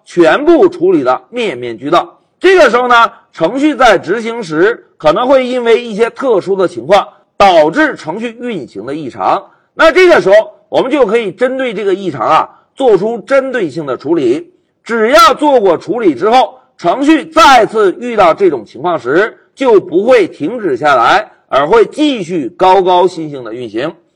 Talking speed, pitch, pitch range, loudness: 255 characters per minute, 300 Hz, 230-360 Hz, -10 LUFS